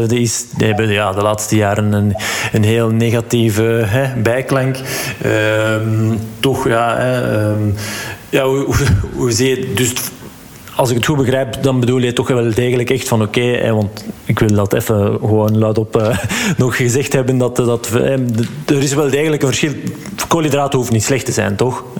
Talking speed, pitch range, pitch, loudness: 195 wpm, 110-130 Hz, 120 Hz, -15 LUFS